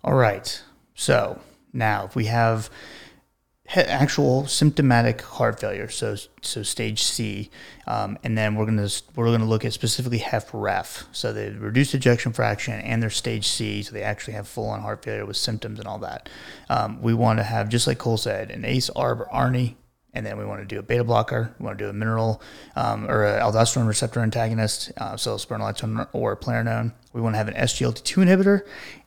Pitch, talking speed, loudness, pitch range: 115 Hz, 200 wpm, -24 LUFS, 110-120 Hz